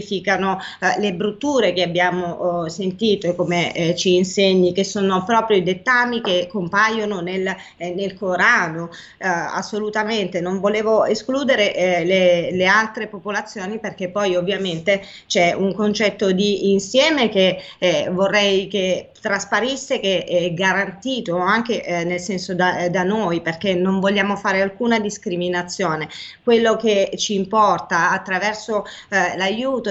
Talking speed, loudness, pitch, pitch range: 135 wpm, -19 LUFS, 195 Hz, 180-210 Hz